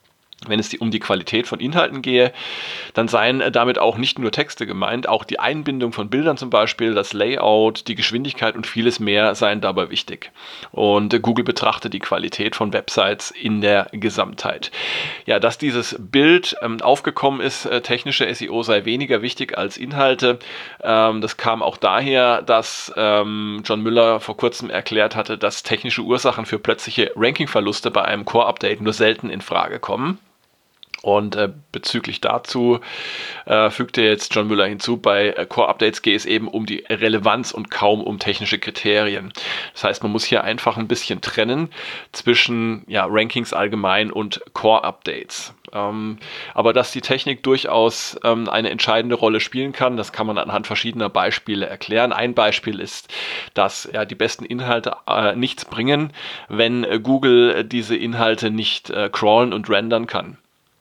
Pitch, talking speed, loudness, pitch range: 115 Hz, 165 wpm, -19 LUFS, 105-120 Hz